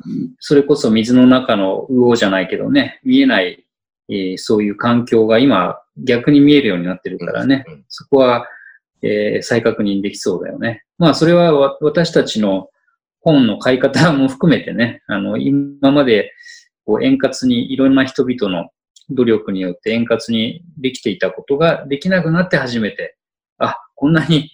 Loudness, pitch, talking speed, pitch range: -15 LUFS, 135 Hz, 315 characters per minute, 115-170 Hz